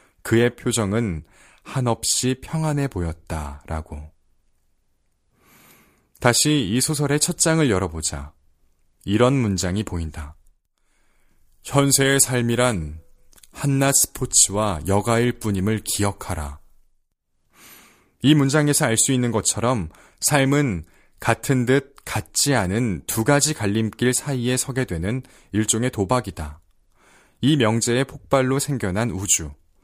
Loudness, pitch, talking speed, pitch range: -20 LUFS, 110 Hz, 225 characters per minute, 85-130 Hz